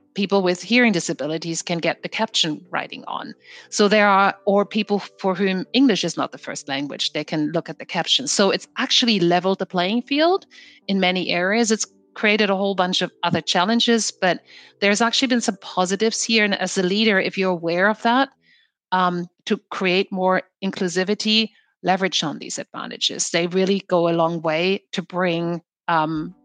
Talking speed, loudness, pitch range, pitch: 185 wpm, -20 LUFS, 175-215 Hz, 190 Hz